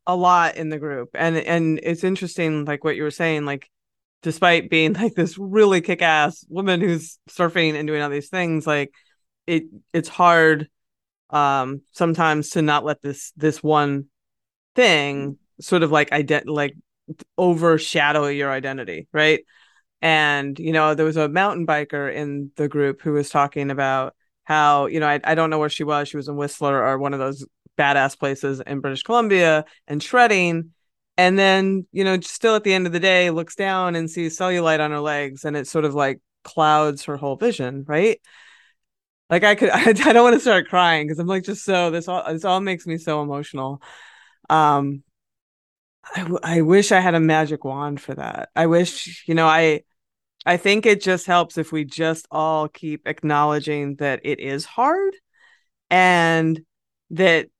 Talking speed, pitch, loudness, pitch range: 185 wpm, 155 Hz, -19 LUFS, 145-175 Hz